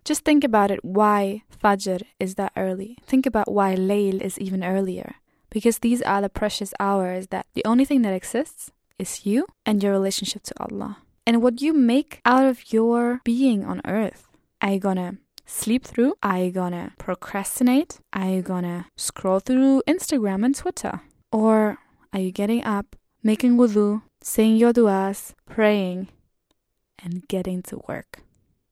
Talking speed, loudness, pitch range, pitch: 160 wpm, -22 LUFS, 195-245 Hz, 210 Hz